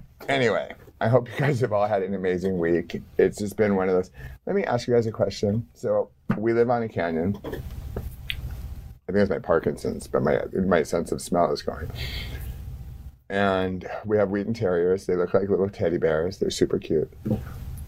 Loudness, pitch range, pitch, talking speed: -25 LUFS, 85-115 Hz, 100 Hz, 190 wpm